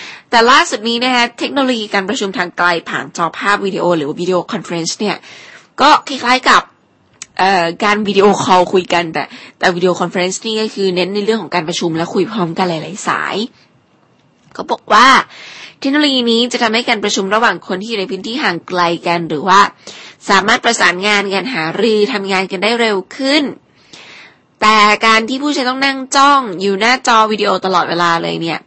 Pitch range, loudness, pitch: 180-230 Hz, -13 LUFS, 205 Hz